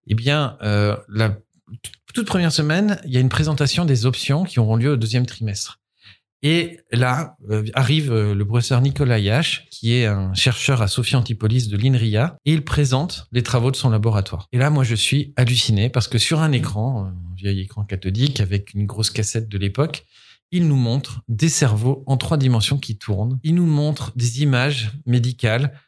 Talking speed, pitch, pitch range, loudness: 190 wpm, 125 Hz, 110-145 Hz, -19 LUFS